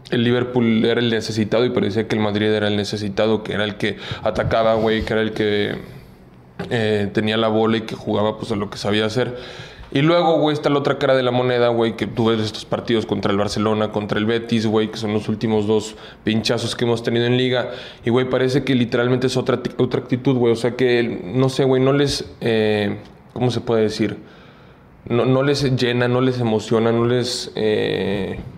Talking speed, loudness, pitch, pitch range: 215 wpm, -19 LUFS, 115 Hz, 110-125 Hz